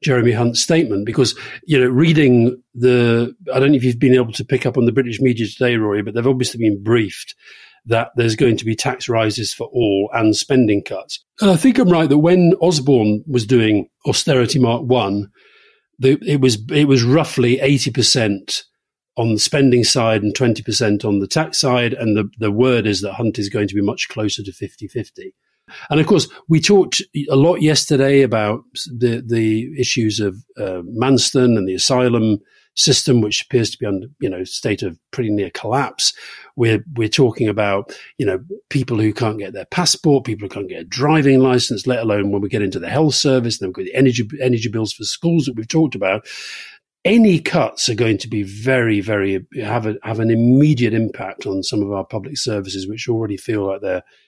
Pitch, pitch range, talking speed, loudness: 120 Hz, 105-135 Hz, 200 wpm, -17 LUFS